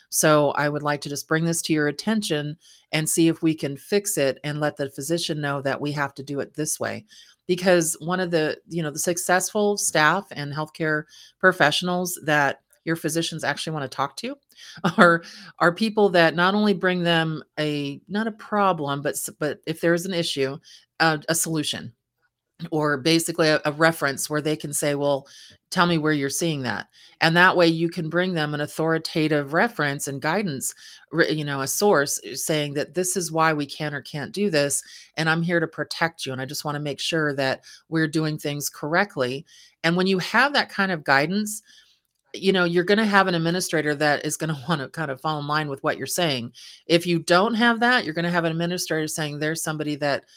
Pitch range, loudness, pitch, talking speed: 145-175 Hz, -23 LUFS, 160 Hz, 210 wpm